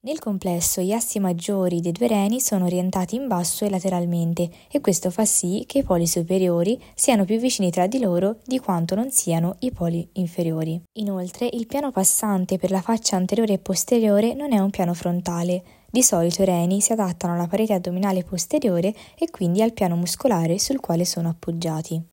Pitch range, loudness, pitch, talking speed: 175-220 Hz, -22 LUFS, 190 Hz, 185 wpm